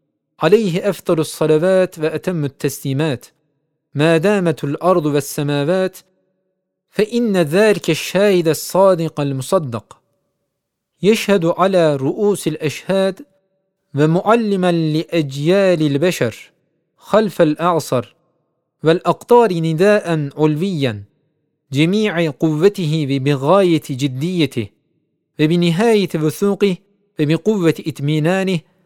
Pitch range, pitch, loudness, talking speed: 155-190 Hz, 165 Hz, -16 LUFS, 70 wpm